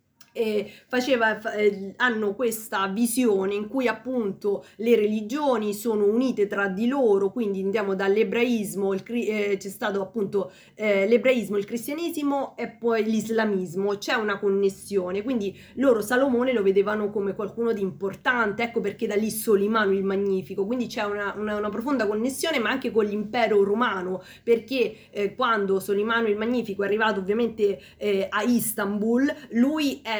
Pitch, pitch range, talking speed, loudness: 215 Hz, 200-235 Hz, 155 wpm, -25 LUFS